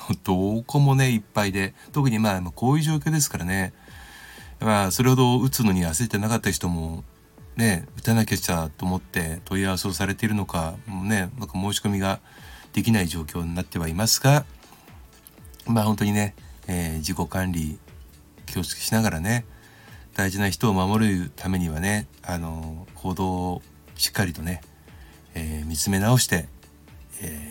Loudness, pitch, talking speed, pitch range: -24 LUFS, 95 Hz, 320 characters per minute, 85-110 Hz